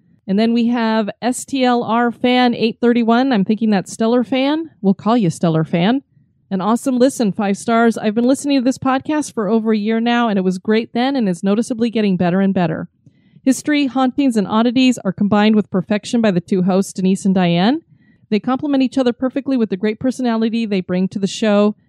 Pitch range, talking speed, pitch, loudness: 195-250 Hz, 205 wpm, 225 Hz, -17 LUFS